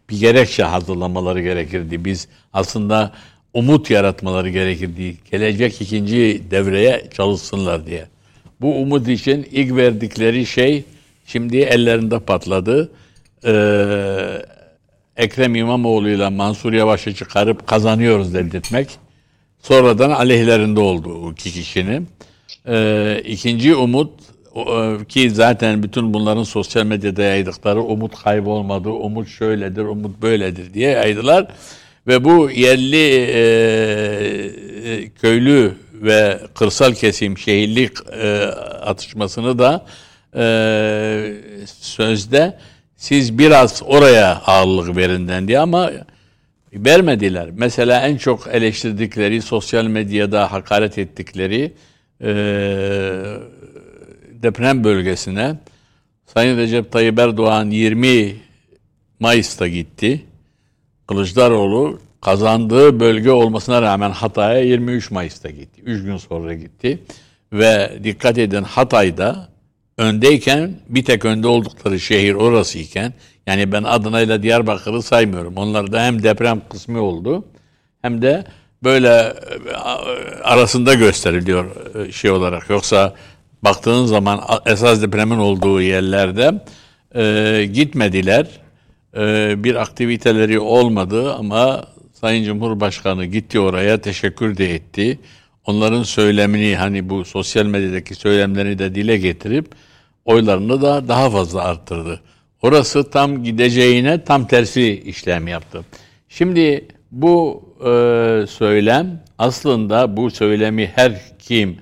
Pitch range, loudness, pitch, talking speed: 100-120 Hz, -15 LUFS, 110 Hz, 100 wpm